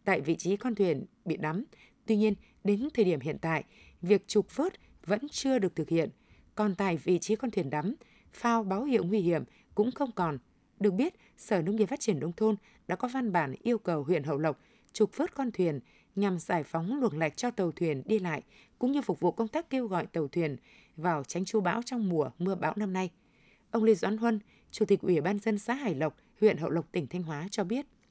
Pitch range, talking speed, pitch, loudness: 170-225 Hz, 235 wpm, 200 Hz, -31 LUFS